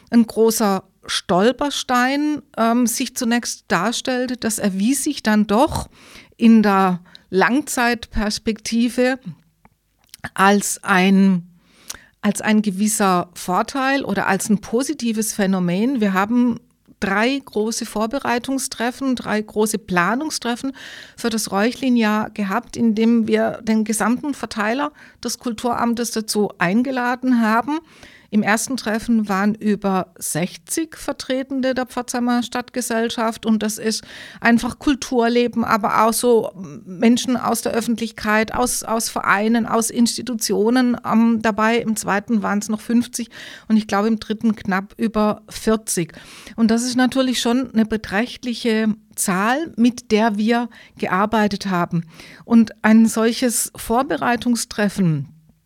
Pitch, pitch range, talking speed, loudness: 225 Hz, 210-245 Hz, 115 wpm, -19 LUFS